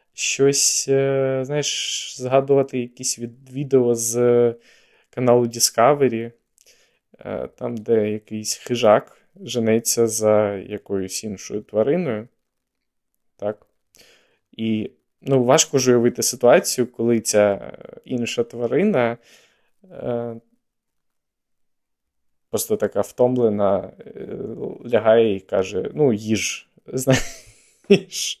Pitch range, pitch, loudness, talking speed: 110-130 Hz, 120 Hz, -20 LUFS, 80 wpm